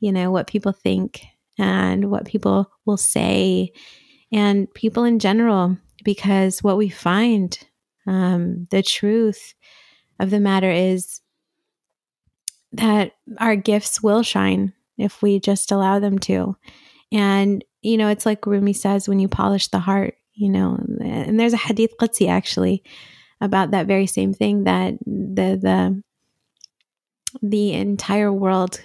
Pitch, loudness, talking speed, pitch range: 200 Hz, -19 LUFS, 140 wpm, 185-210 Hz